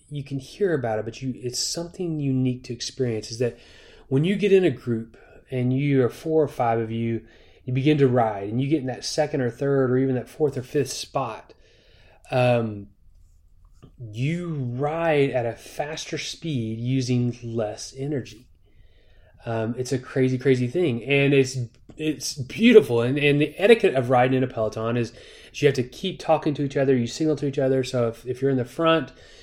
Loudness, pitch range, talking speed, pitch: -23 LUFS, 115-145 Hz, 200 wpm, 130 Hz